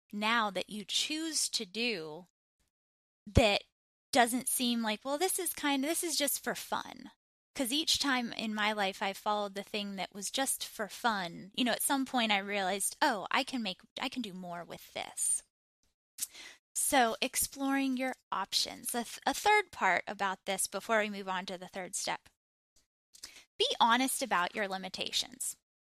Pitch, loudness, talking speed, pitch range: 220 Hz, -32 LUFS, 175 wpm, 195-265 Hz